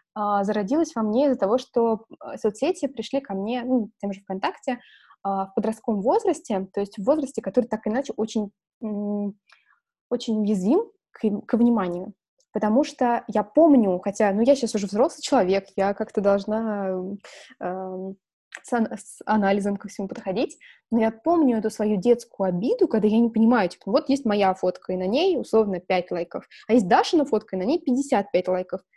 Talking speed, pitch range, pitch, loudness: 170 wpm, 200-255 Hz, 220 Hz, -24 LUFS